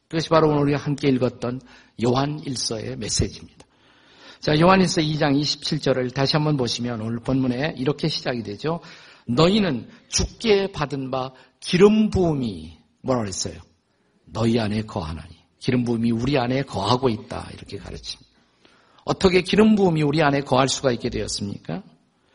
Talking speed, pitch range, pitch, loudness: 330 characters per minute, 115-150 Hz, 130 Hz, -22 LUFS